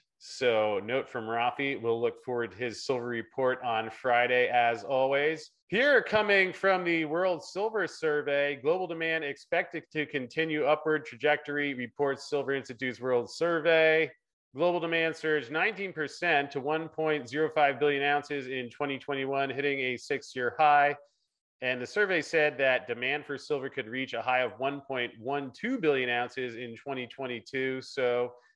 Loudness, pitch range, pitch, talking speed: -29 LUFS, 125-155 Hz, 140 Hz, 145 wpm